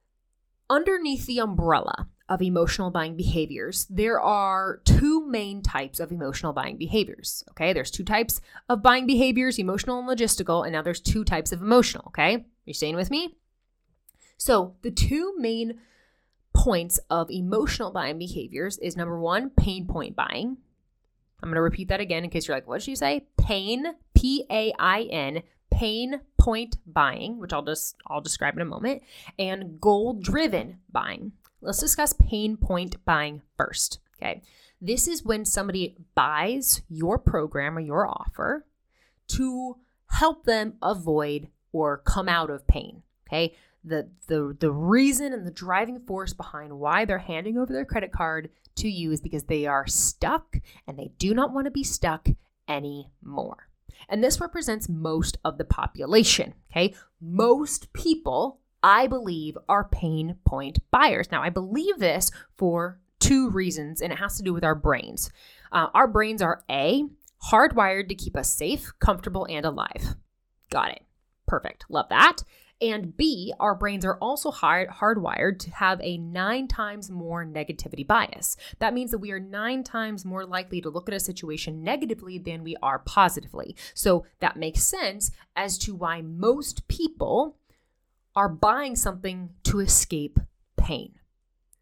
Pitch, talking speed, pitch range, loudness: 190 Hz, 160 wpm, 165-235 Hz, -25 LUFS